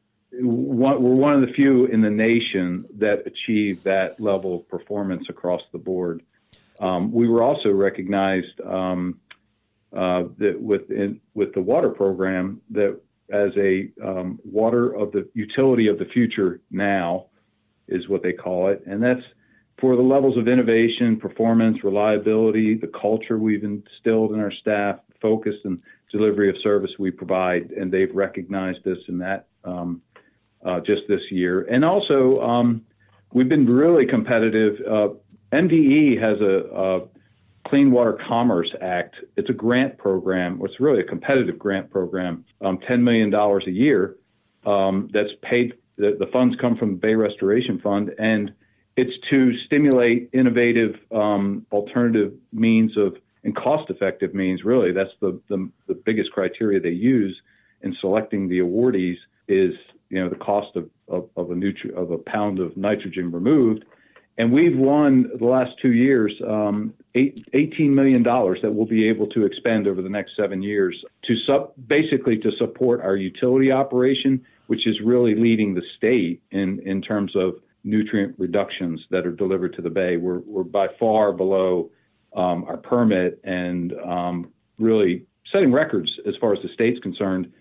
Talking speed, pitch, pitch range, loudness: 160 wpm, 105 Hz, 95-120 Hz, -21 LUFS